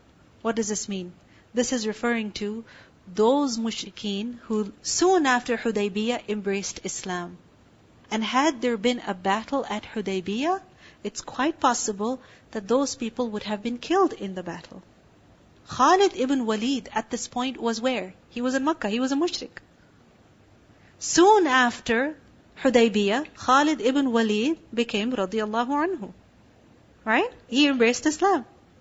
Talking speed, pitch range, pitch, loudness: 135 wpm, 210-270 Hz, 235 Hz, -25 LUFS